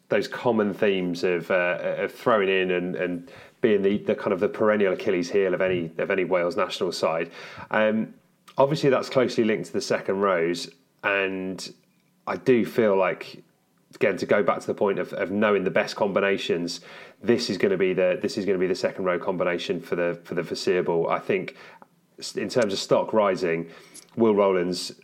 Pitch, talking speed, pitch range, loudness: 90 Hz, 195 wpm, 85-100 Hz, -24 LUFS